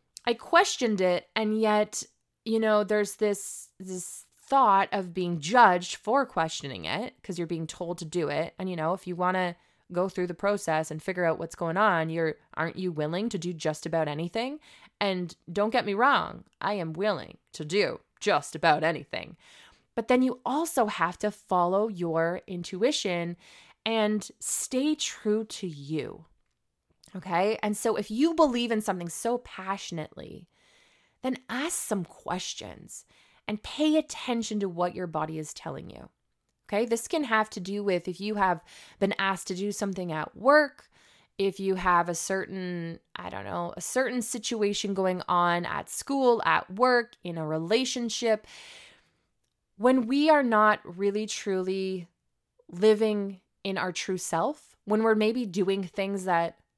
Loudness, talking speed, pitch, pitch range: -28 LUFS, 165 wpm, 195 Hz, 175-225 Hz